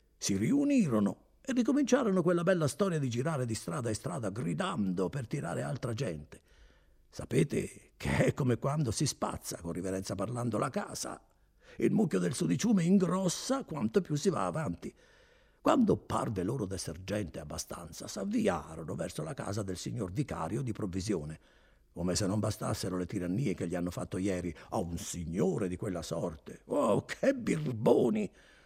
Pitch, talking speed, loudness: 105 Hz, 155 wpm, -33 LUFS